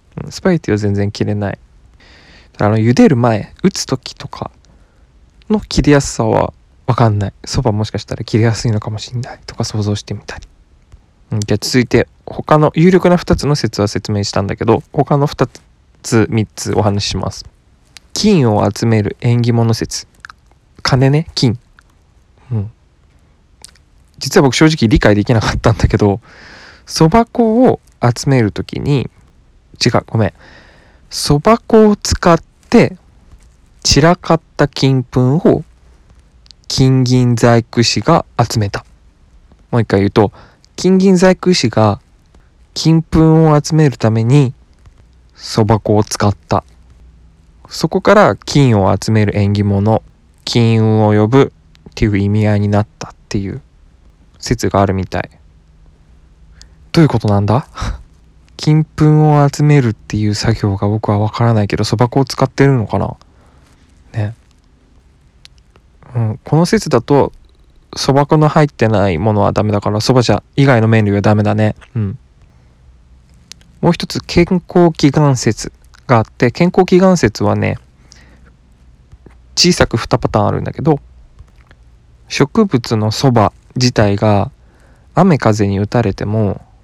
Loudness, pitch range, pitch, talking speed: -13 LUFS, 90-135 Hz, 110 Hz, 255 characters per minute